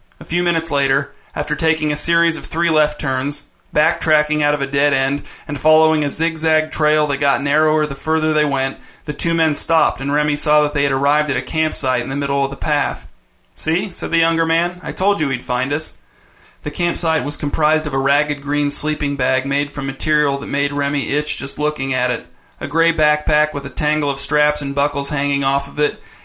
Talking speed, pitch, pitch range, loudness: 220 wpm, 145 Hz, 140-155 Hz, -18 LUFS